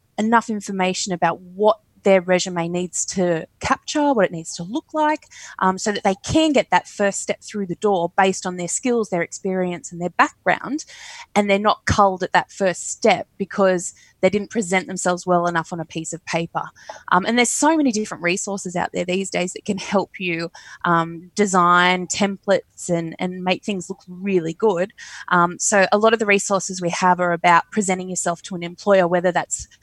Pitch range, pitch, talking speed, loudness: 175-205 Hz, 185 Hz, 200 wpm, -20 LUFS